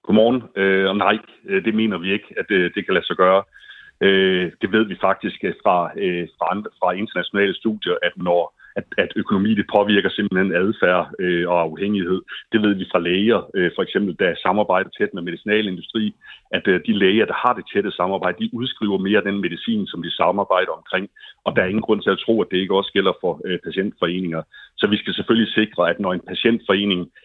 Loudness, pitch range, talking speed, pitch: -20 LUFS, 90-110 Hz, 185 wpm, 100 Hz